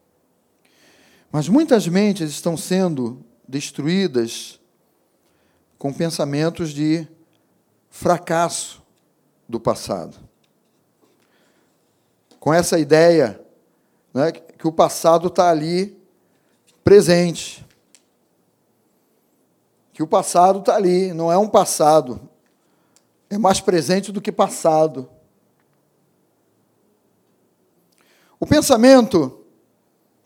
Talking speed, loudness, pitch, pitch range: 75 wpm, -18 LUFS, 170 Hz, 155-190 Hz